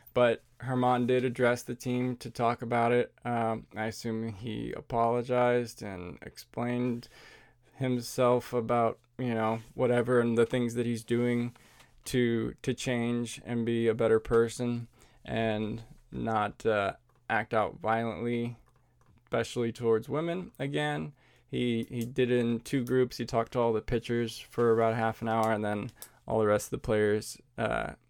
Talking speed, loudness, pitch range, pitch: 155 wpm, -30 LUFS, 115-125 Hz, 120 Hz